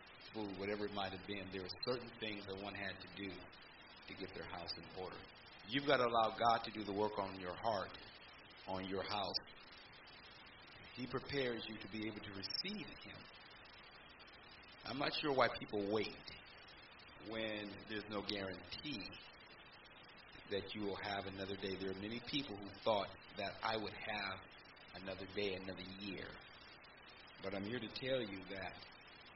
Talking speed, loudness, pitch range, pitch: 170 wpm, -43 LUFS, 95-110 Hz, 100 Hz